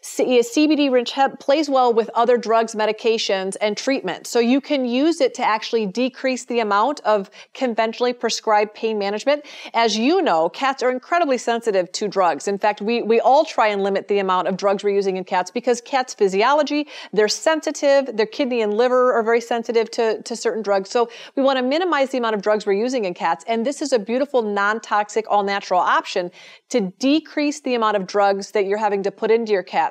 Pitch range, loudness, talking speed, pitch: 210-255 Hz, -20 LUFS, 200 wpm, 230 Hz